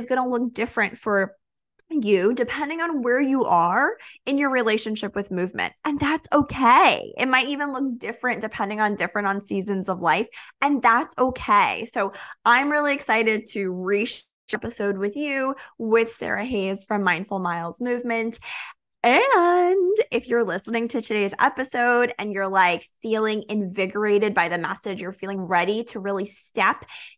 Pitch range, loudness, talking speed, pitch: 200-255 Hz, -22 LUFS, 160 wpm, 225 Hz